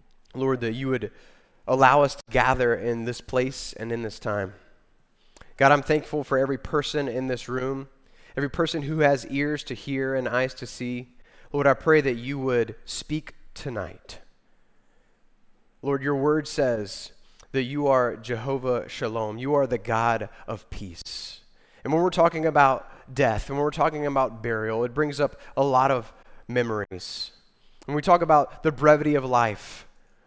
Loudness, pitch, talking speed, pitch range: -25 LUFS, 130 Hz, 170 wpm, 120-145 Hz